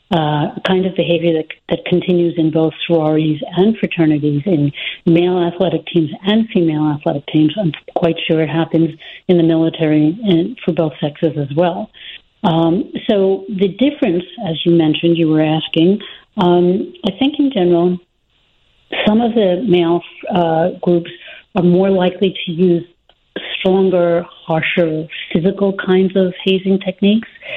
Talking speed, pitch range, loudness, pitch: 150 wpm, 165-190 Hz, -15 LUFS, 175 Hz